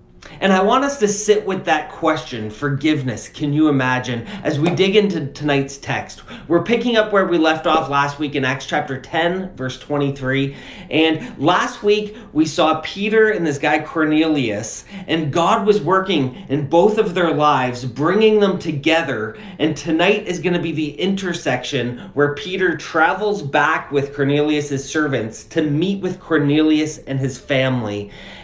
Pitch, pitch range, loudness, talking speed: 155 Hz, 140-185 Hz, -18 LUFS, 165 wpm